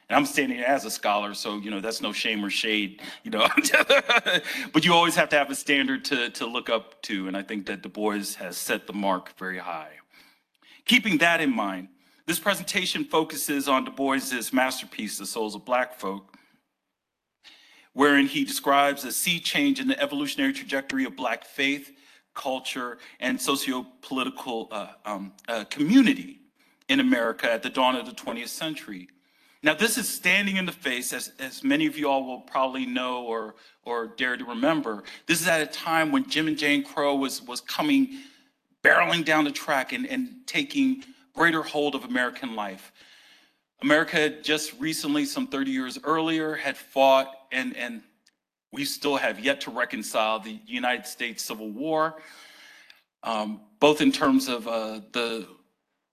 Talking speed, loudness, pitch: 170 wpm, -25 LUFS, 145 Hz